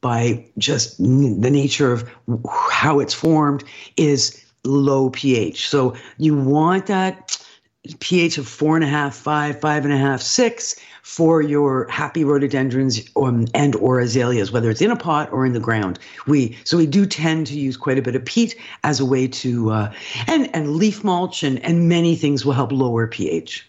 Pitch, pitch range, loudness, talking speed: 140 Hz, 125-155 Hz, -19 LUFS, 180 wpm